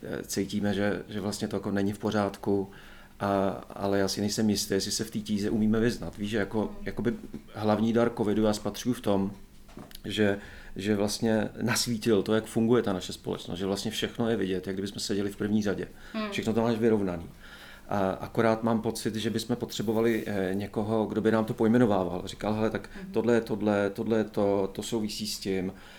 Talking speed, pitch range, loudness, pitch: 195 wpm, 100-115 Hz, -29 LUFS, 105 Hz